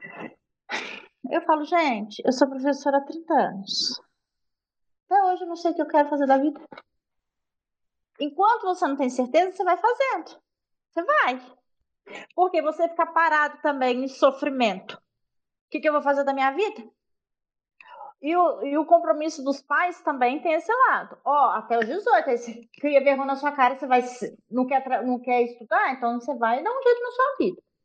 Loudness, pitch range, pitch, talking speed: -23 LUFS, 260-340 Hz, 295 Hz, 185 wpm